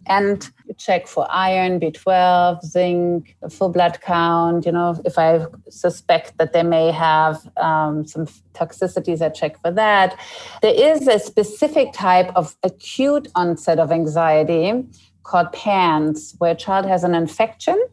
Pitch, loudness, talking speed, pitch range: 175 Hz, -18 LUFS, 145 wpm, 165-190 Hz